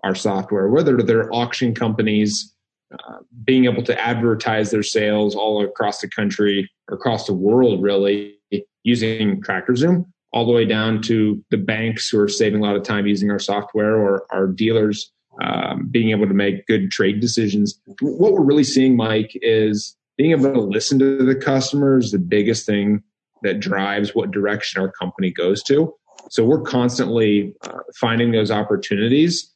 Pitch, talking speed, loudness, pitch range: 110 Hz, 170 wpm, -18 LUFS, 105-120 Hz